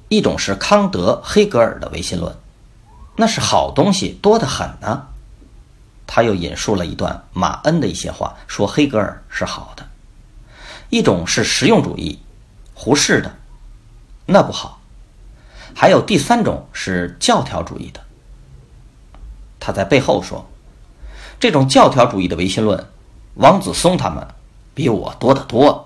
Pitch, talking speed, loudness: 120 Hz, 210 characters per minute, -16 LUFS